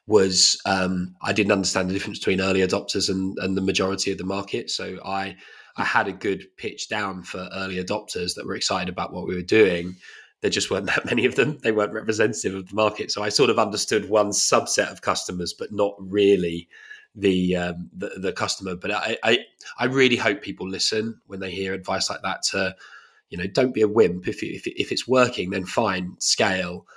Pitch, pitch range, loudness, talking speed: 95 Hz, 95-105 Hz, -23 LUFS, 215 wpm